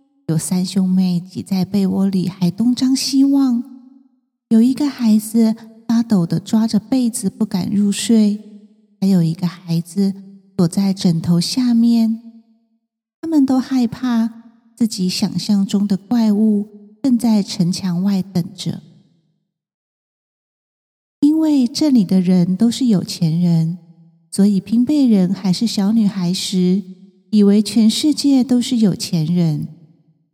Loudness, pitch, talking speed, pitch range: -17 LUFS, 205 Hz, 185 characters per minute, 185-230 Hz